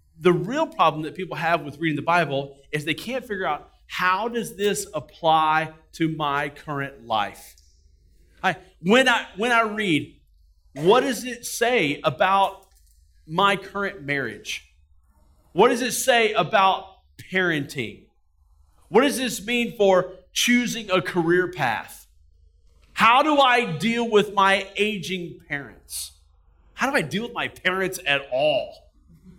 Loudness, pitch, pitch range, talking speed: -22 LUFS, 175 Hz, 130-205 Hz, 140 wpm